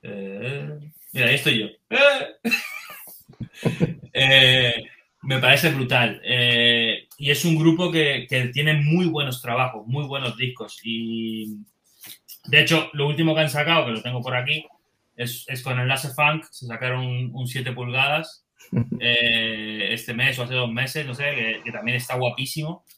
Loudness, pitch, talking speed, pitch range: -21 LUFS, 130 Hz, 160 wpm, 120-150 Hz